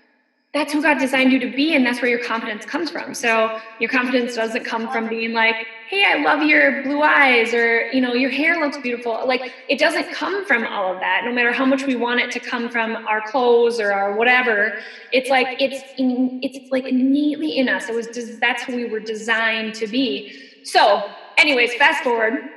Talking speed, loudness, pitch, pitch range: 215 wpm, -18 LUFS, 250 Hz, 230-275 Hz